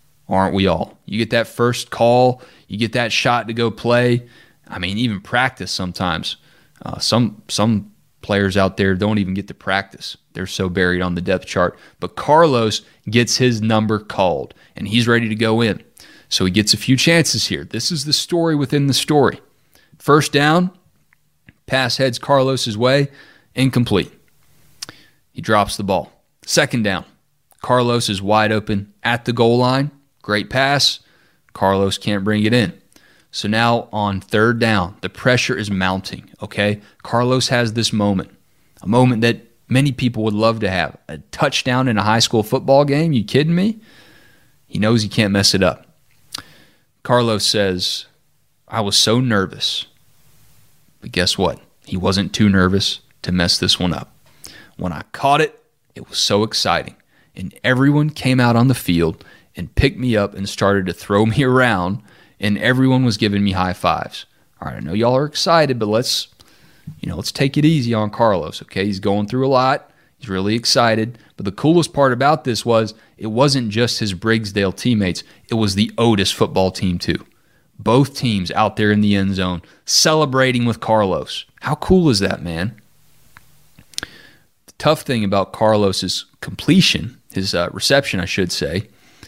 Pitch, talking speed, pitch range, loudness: 115 Hz, 175 wpm, 100-130 Hz, -17 LUFS